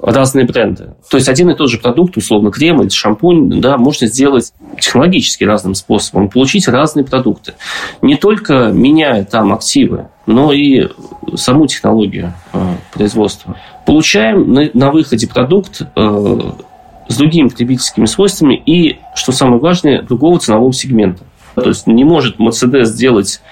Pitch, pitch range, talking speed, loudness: 130 Hz, 110-155 Hz, 135 wpm, -10 LUFS